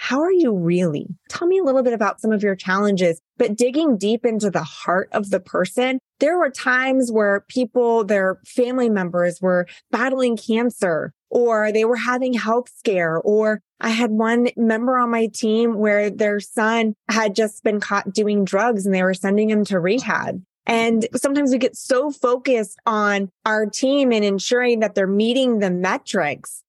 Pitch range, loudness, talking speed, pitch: 200-245 Hz, -19 LUFS, 180 wpm, 220 Hz